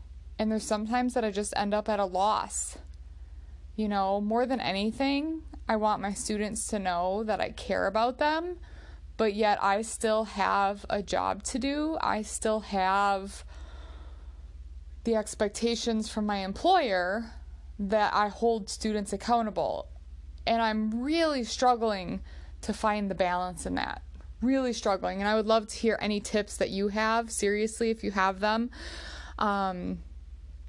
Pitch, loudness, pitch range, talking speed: 210 Hz, -29 LUFS, 185-225 Hz, 155 wpm